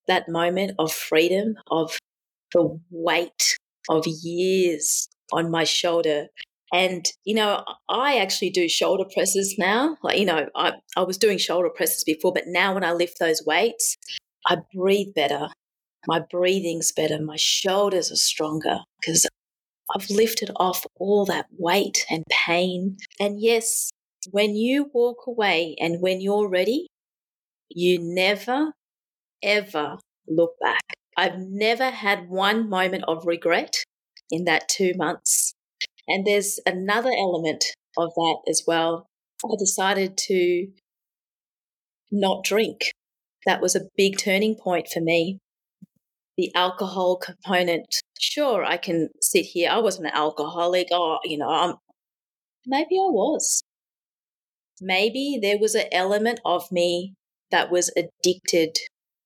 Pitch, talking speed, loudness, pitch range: 185 Hz, 135 wpm, -23 LUFS, 170-205 Hz